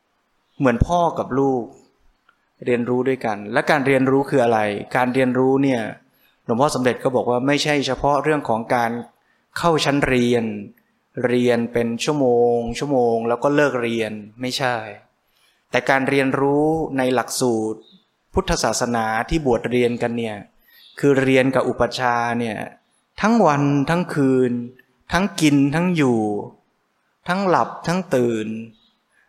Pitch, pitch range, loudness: 125 Hz, 120-140 Hz, -20 LUFS